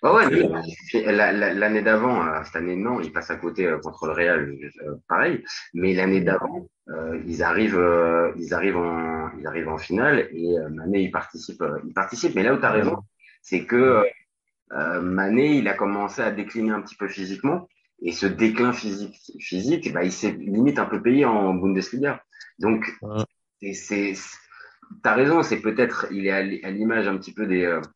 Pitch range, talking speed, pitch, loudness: 85-105 Hz, 170 wpm, 95 Hz, -23 LUFS